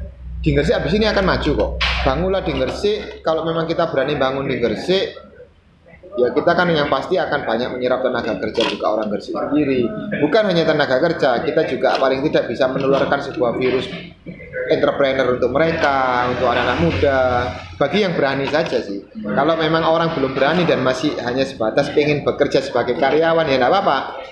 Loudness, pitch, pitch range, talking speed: -18 LUFS, 135 Hz, 125-160 Hz, 170 wpm